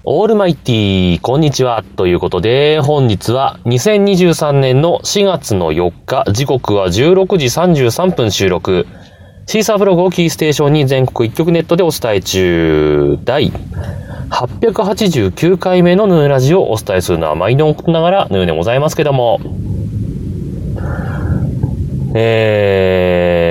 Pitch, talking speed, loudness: 130 Hz, 250 characters per minute, -12 LUFS